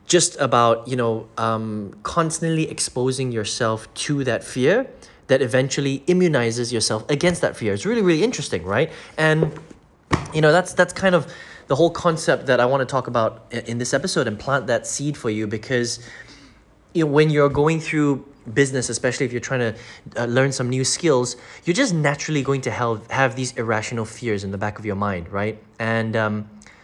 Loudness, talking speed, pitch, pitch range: -21 LUFS, 185 wpm, 125 Hz, 110-150 Hz